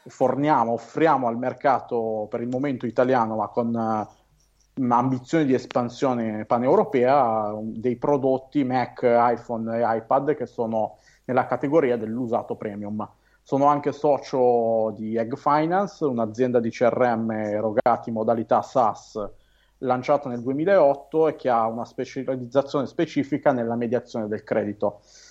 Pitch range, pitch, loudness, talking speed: 115-135 Hz, 125 Hz, -23 LUFS, 125 wpm